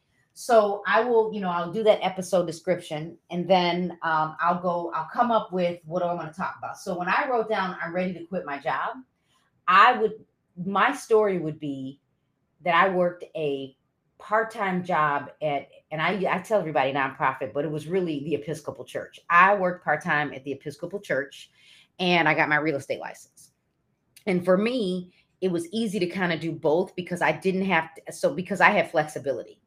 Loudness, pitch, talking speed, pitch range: -25 LUFS, 175 Hz, 200 wpm, 155-190 Hz